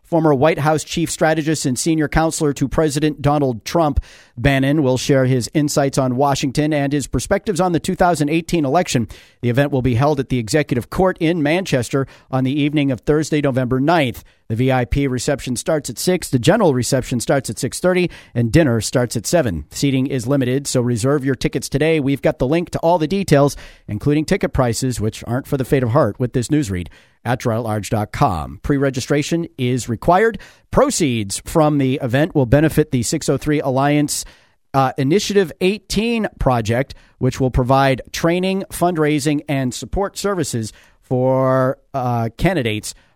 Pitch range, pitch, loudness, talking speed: 130-155 Hz, 140 Hz, -18 LUFS, 165 wpm